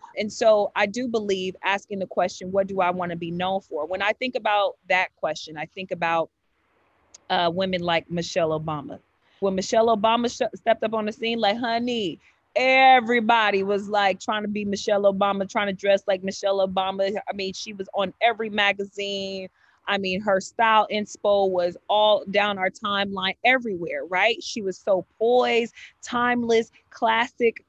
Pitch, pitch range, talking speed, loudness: 200 Hz, 190-225 Hz, 175 wpm, -23 LUFS